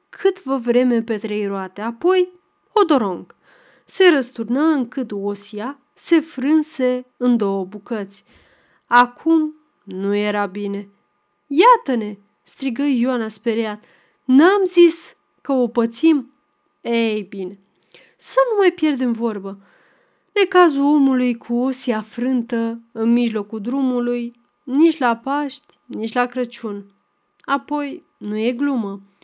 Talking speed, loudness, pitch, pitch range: 115 wpm, -19 LUFS, 245 Hz, 215-295 Hz